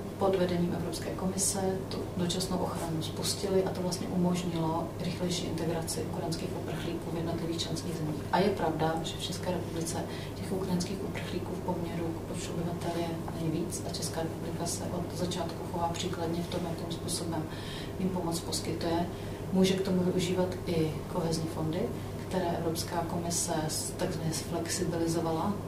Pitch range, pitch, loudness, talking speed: 165-185 Hz, 180 Hz, -32 LUFS, 150 wpm